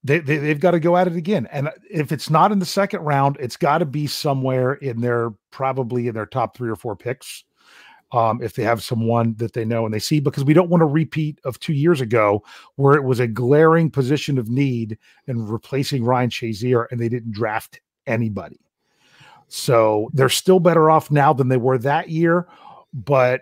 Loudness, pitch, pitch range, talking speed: -19 LUFS, 135 Hz, 115-155 Hz, 210 wpm